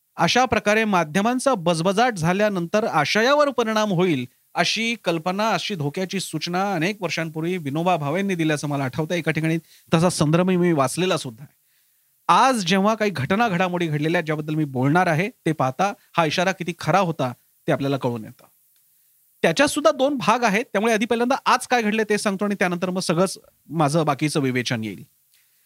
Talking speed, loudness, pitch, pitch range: 165 wpm, -21 LUFS, 180 Hz, 155-210 Hz